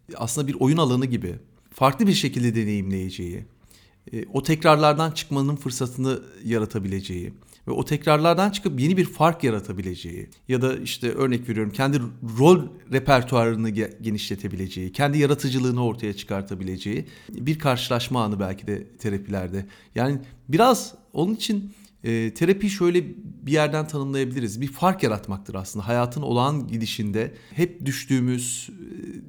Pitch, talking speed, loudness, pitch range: 125 Hz, 120 wpm, -24 LUFS, 110-150 Hz